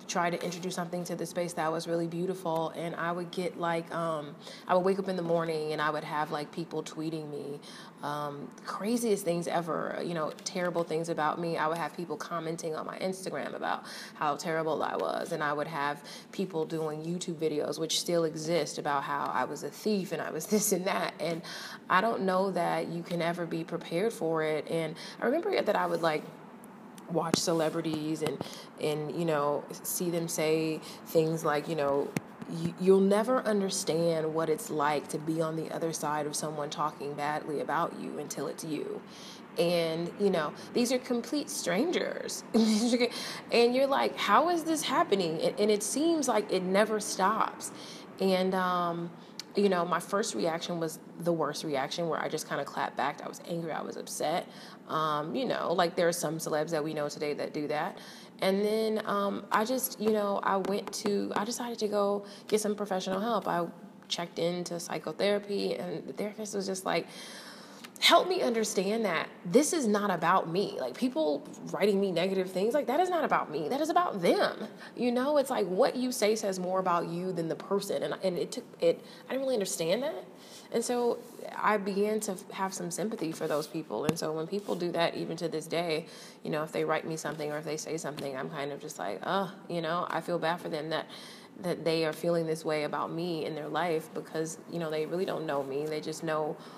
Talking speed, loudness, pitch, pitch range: 210 wpm, -31 LUFS, 175 Hz, 160-205 Hz